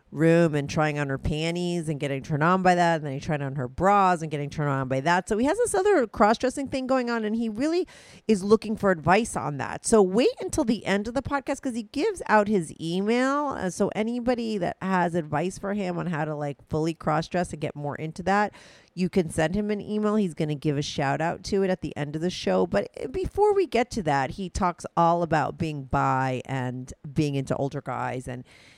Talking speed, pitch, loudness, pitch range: 240 wpm, 180 Hz, -25 LUFS, 150-220 Hz